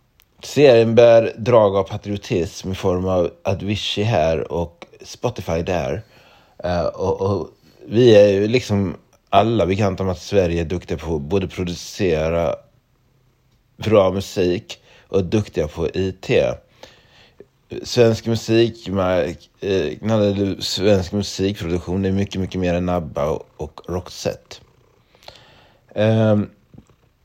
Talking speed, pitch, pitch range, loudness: 120 wpm, 100 Hz, 90-115 Hz, -19 LUFS